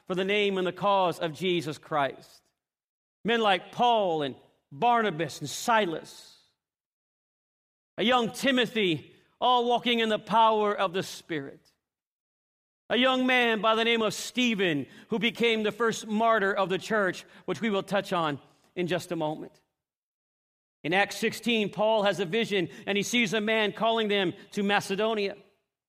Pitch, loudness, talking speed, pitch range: 200 Hz, -27 LUFS, 160 wpm, 175-225 Hz